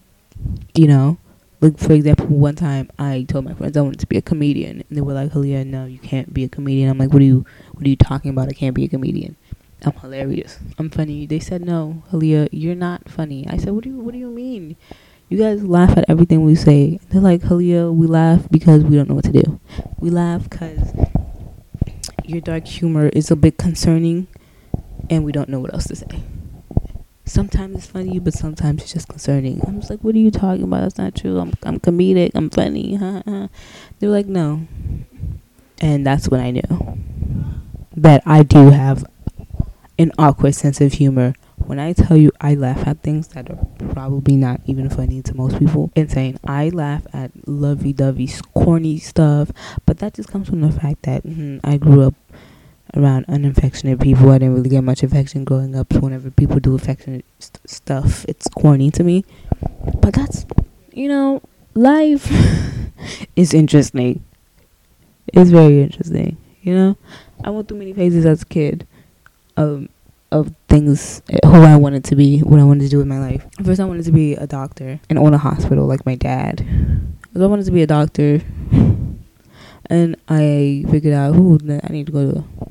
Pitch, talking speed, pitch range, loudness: 145 Hz, 195 wpm, 135-165 Hz, -15 LUFS